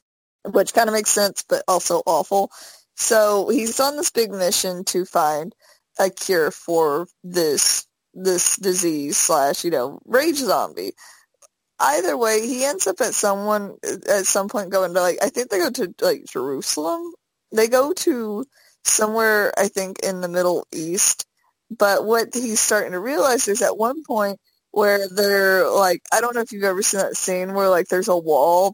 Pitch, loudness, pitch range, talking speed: 200 Hz, -20 LUFS, 185-230 Hz, 175 wpm